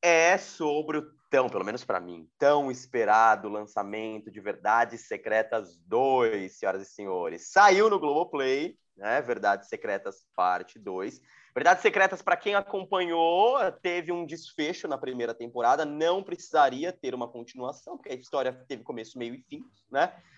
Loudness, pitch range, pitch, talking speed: -27 LUFS, 115-180 Hz, 145 Hz, 150 wpm